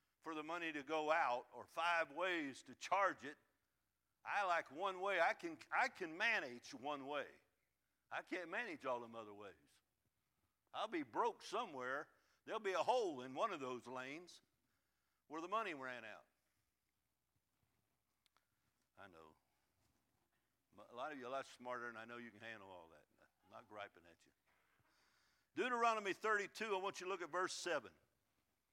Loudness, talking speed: -43 LUFS, 170 wpm